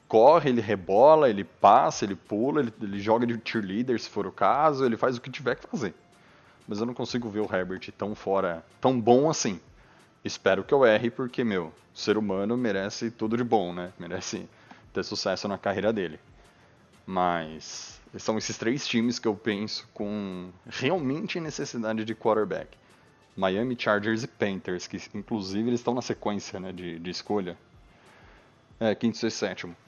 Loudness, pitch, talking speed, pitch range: -27 LUFS, 110 Hz, 170 wpm, 95-120 Hz